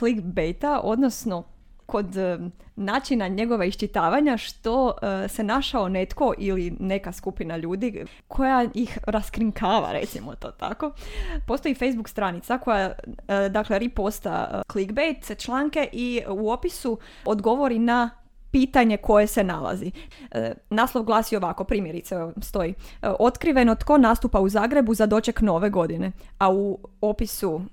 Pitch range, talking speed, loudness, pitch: 195-245 Hz, 115 wpm, -24 LUFS, 215 Hz